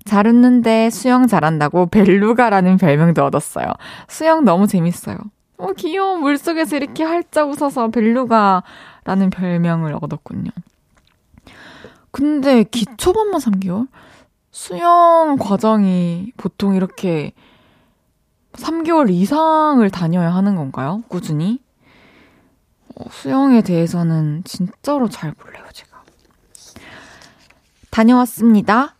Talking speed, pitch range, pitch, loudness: 235 characters per minute, 180-275 Hz, 215 Hz, -15 LUFS